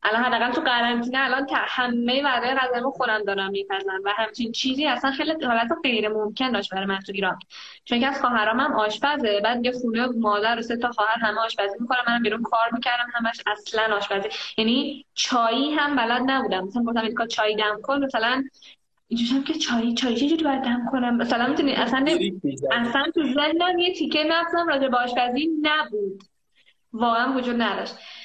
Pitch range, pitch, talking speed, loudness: 220-270 Hz, 240 Hz, 185 wpm, -23 LUFS